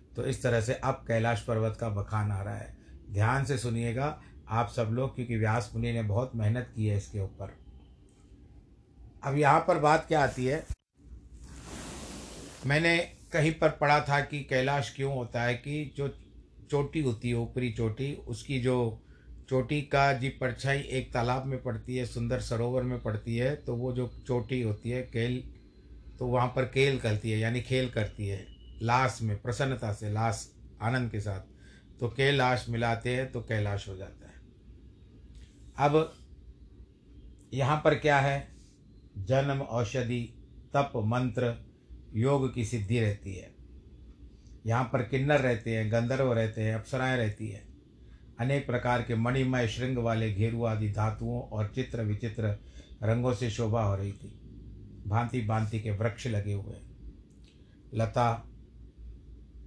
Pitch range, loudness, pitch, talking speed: 105-130 Hz, -30 LUFS, 115 Hz, 155 wpm